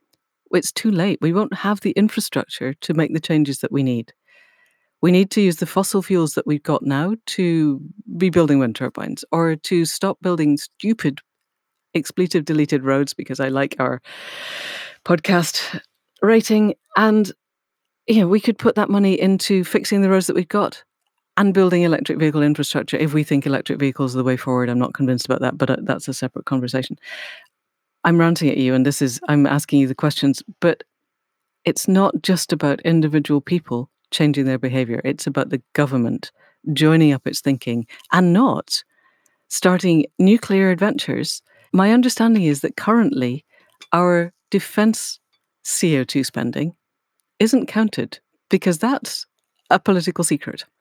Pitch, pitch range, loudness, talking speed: 165 Hz, 140-195 Hz, -19 LUFS, 160 wpm